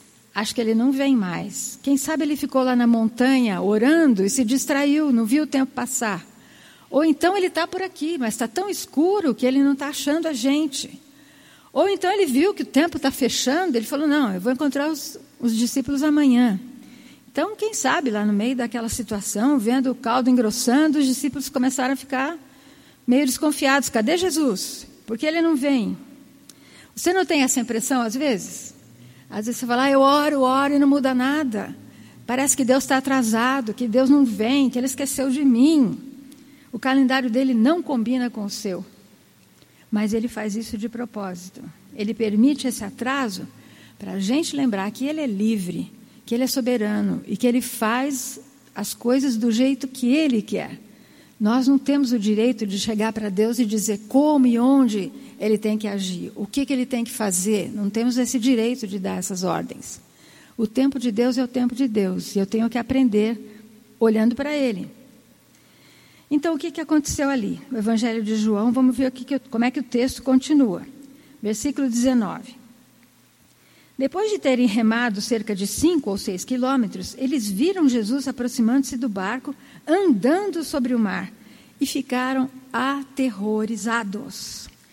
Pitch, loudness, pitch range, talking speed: 255 Hz, -21 LUFS, 225-275 Hz, 175 wpm